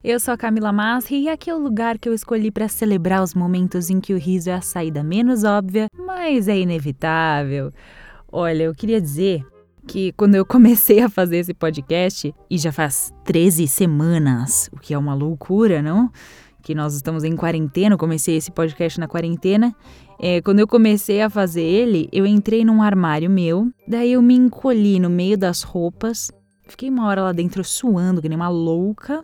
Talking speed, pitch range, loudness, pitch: 190 wpm, 165-220 Hz, -18 LUFS, 185 Hz